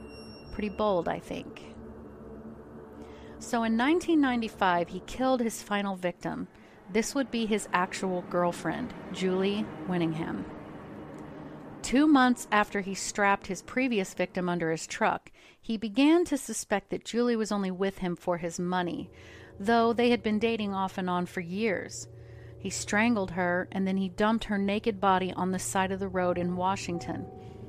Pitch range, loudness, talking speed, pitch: 175-220 Hz, -29 LUFS, 155 wpm, 190 Hz